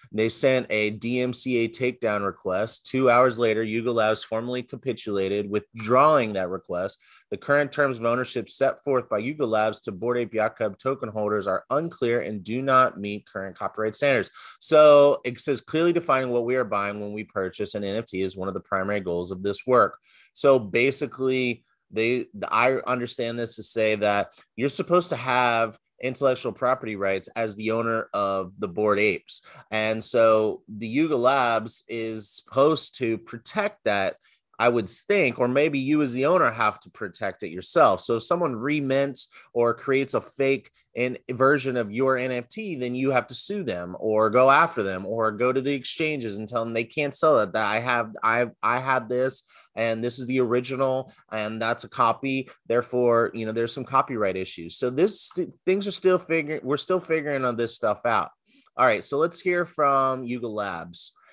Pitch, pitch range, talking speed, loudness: 120 Hz, 110-135 Hz, 185 wpm, -24 LUFS